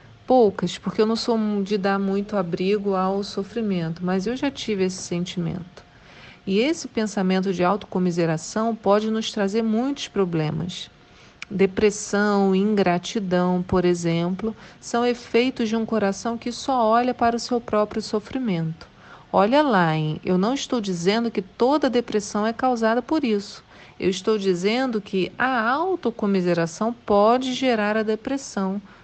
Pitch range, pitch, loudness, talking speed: 190-230 Hz, 210 Hz, -23 LUFS, 140 wpm